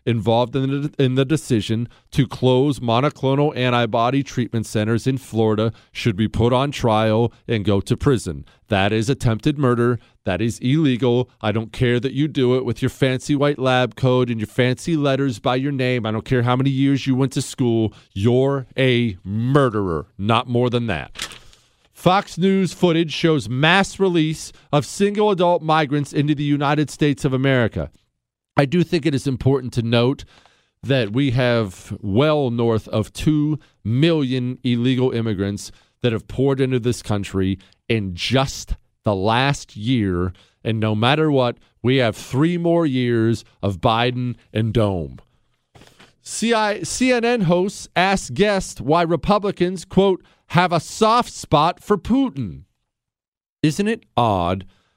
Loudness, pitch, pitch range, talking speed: -20 LUFS, 125 Hz, 115-145 Hz, 155 wpm